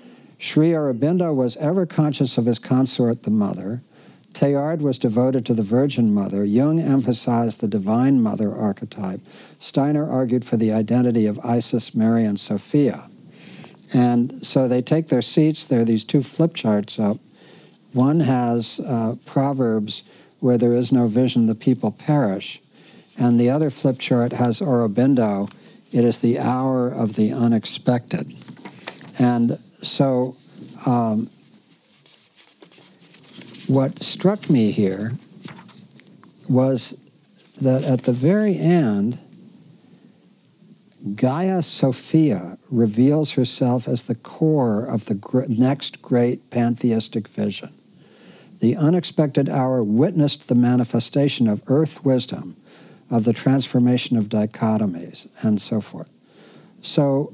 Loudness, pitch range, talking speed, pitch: -20 LUFS, 120-150 Hz, 120 wpm, 130 Hz